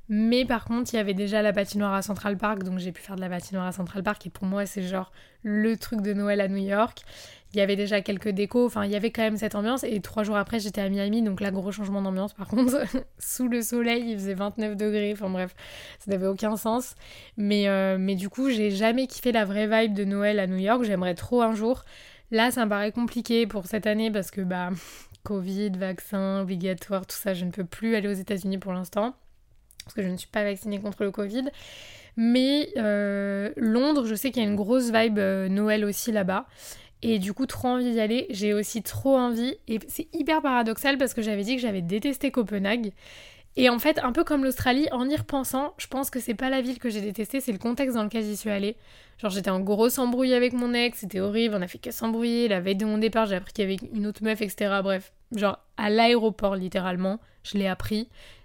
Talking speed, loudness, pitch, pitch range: 240 wpm, -26 LUFS, 210 Hz, 200-235 Hz